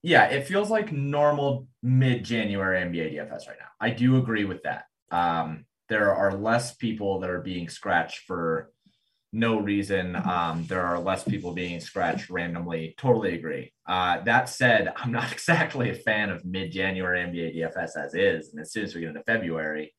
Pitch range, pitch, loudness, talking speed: 85-115 Hz, 95 Hz, -26 LUFS, 185 wpm